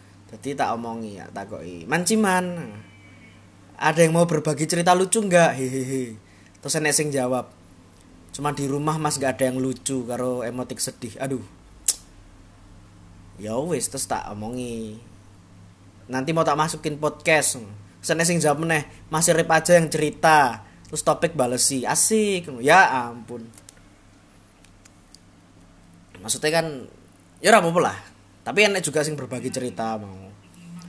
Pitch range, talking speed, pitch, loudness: 100-155 Hz, 130 wpm, 125 Hz, -22 LUFS